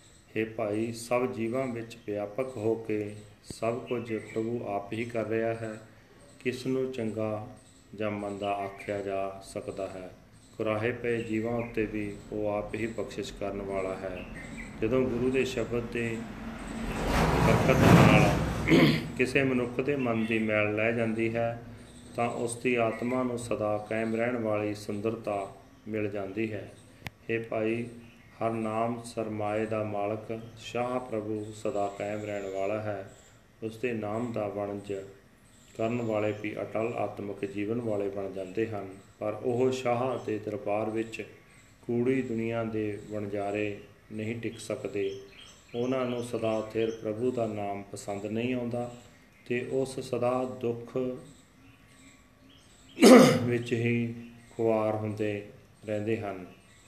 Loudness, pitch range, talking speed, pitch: -30 LUFS, 105-120 Hz, 135 wpm, 110 Hz